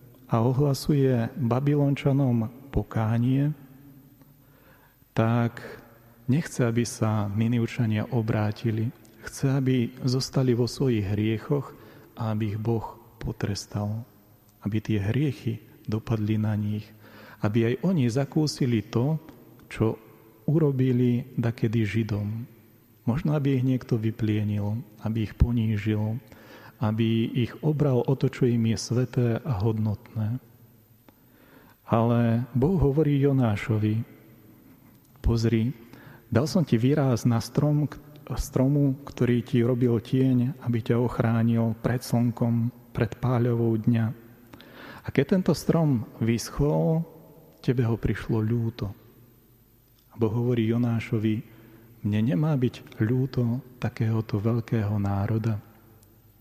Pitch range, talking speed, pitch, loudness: 110-130 Hz, 100 wpm, 120 Hz, -26 LUFS